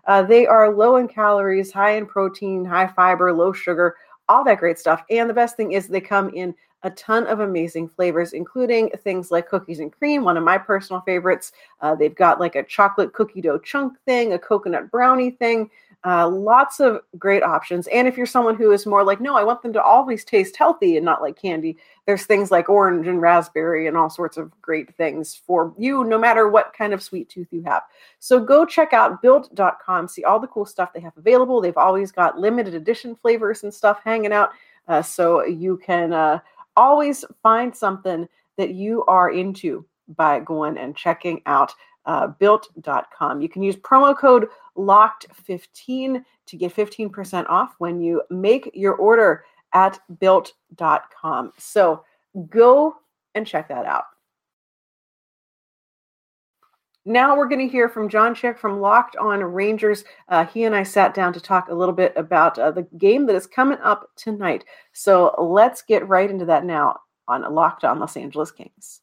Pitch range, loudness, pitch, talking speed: 180-235 Hz, -18 LUFS, 200 Hz, 185 wpm